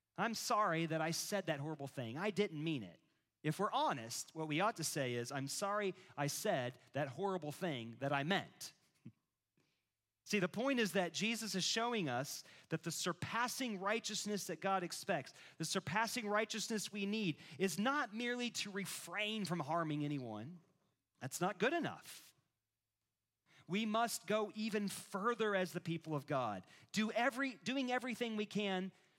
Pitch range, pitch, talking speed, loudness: 150-215 Hz, 185 Hz, 165 wpm, -40 LUFS